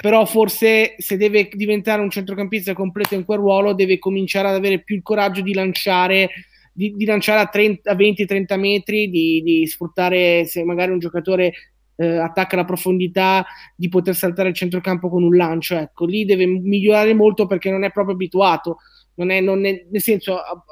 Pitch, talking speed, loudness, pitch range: 190 Hz, 175 wpm, -17 LUFS, 180-205 Hz